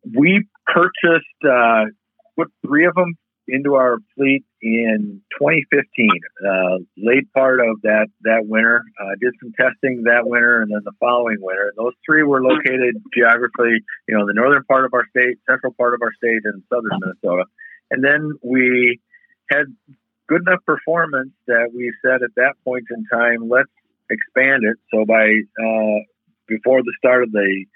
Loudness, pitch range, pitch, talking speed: -17 LUFS, 110-135 Hz, 120 Hz, 170 wpm